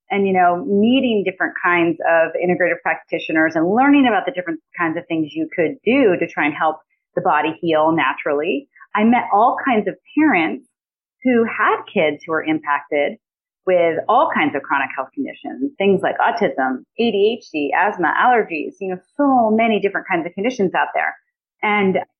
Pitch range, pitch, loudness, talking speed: 165-225 Hz, 185 Hz, -18 LUFS, 175 wpm